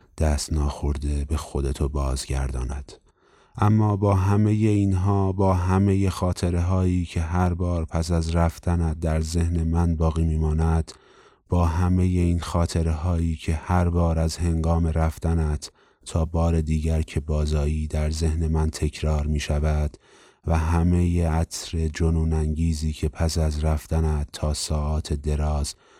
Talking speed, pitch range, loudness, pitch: 135 wpm, 75-85 Hz, -24 LUFS, 80 Hz